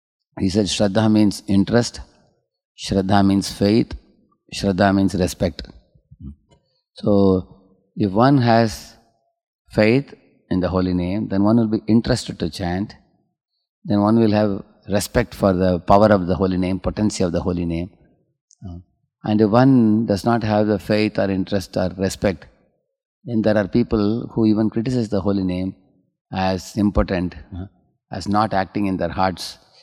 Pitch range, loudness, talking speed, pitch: 95-110 Hz, -19 LUFS, 150 wpm, 100 Hz